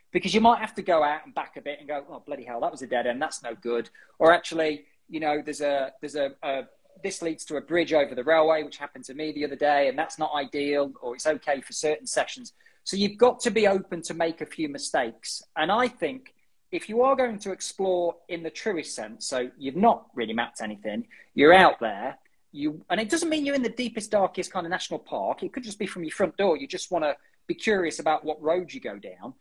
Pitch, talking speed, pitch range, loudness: 170 Hz, 255 wpm, 145-220 Hz, -26 LUFS